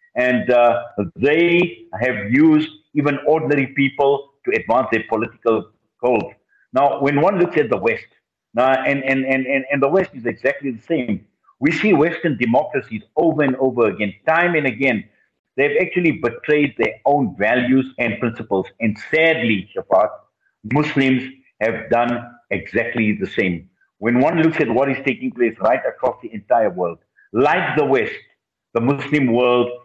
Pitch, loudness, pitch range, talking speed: 130 Hz, -18 LUFS, 120-150 Hz, 155 wpm